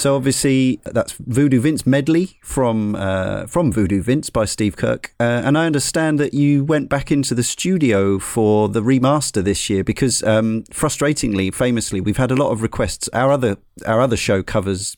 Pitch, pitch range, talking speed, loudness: 125 Hz, 105-140 Hz, 185 wpm, -18 LUFS